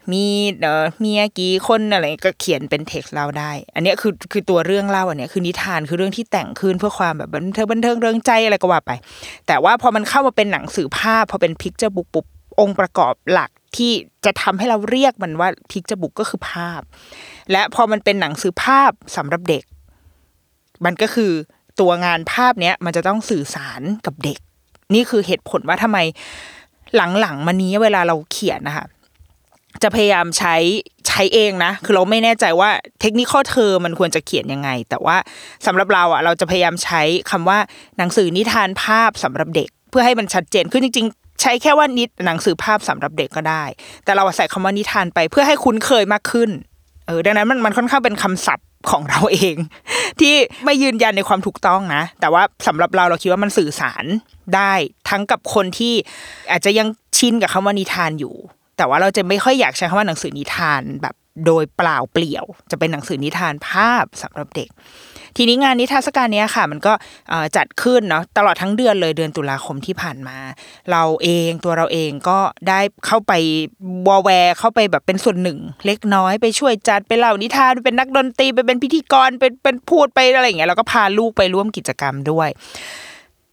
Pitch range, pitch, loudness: 170-225 Hz, 195 Hz, -16 LUFS